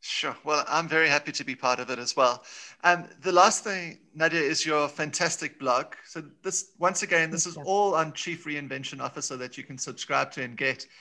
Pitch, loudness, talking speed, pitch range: 160 Hz, -26 LUFS, 220 wpm, 145-175 Hz